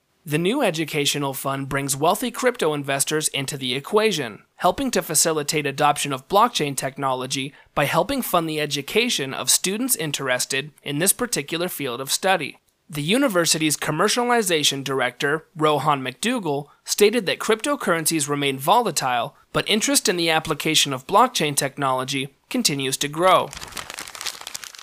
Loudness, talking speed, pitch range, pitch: -21 LUFS, 130 wpm, 140-200 Hz, 155 Hz